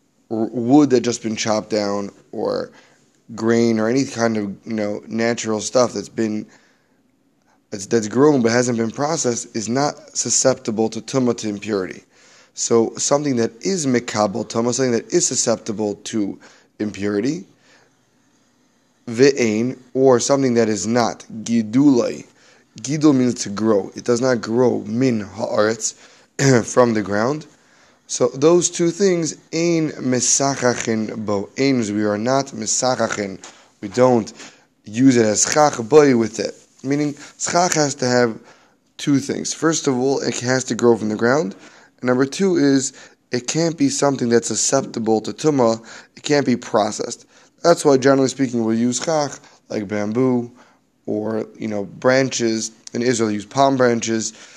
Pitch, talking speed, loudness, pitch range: 120 Hz, 150 wpm, -19 LUFS, 110-135 Hz